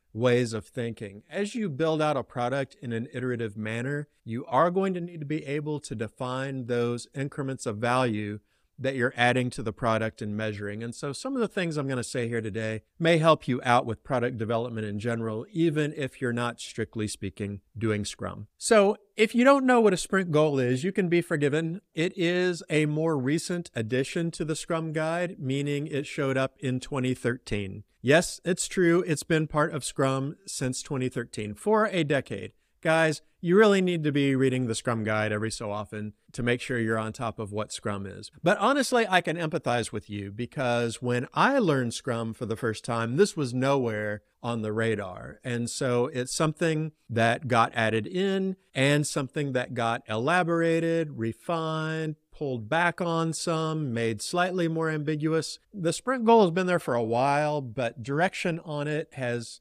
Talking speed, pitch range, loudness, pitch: 190 wpm, 115-160 Hz, -27 LUFS, 135 Hz